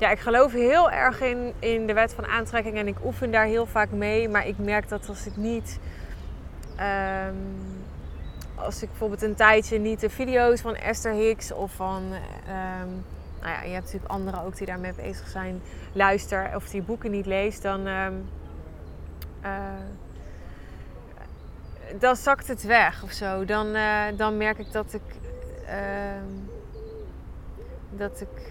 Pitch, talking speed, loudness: 200 Hz, 160 wpm, -26 LUFS